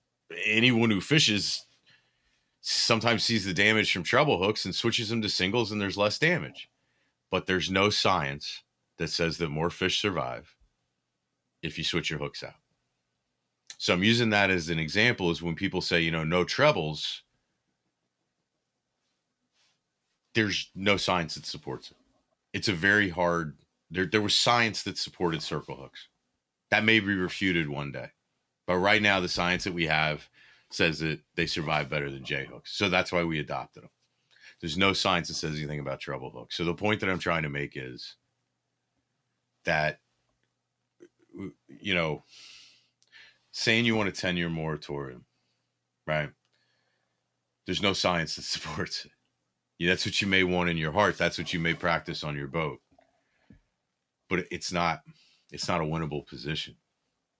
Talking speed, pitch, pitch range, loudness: 160 wpm, 85 Hz, 75-100 Hz, -27 LUFS